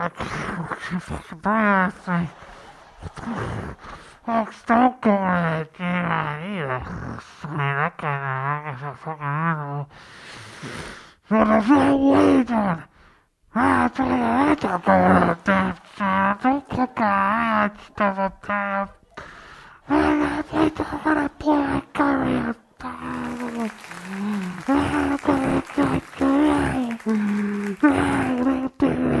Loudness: -22 LUFS